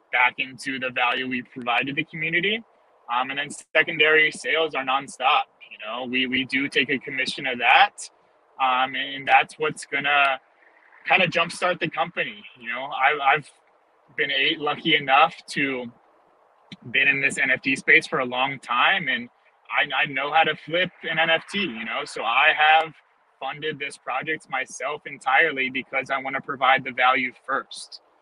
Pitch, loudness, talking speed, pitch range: 140 Hz, -22 LUFS, 170 wpm, 130-160 Hz